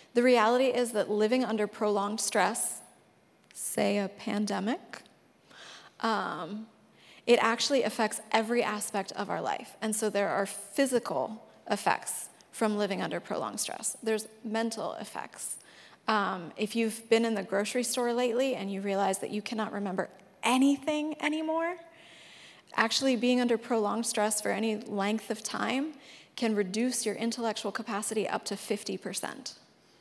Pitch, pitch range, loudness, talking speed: 220 Hz, 210-245 Hz, -30 LUFS, 140 wpm